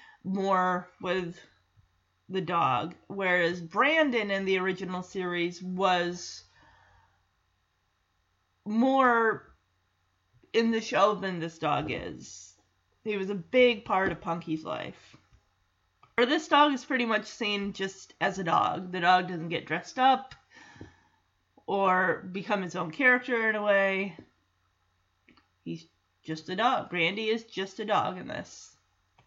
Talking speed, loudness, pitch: 130 wpm, -28 LUFS, 180 Hz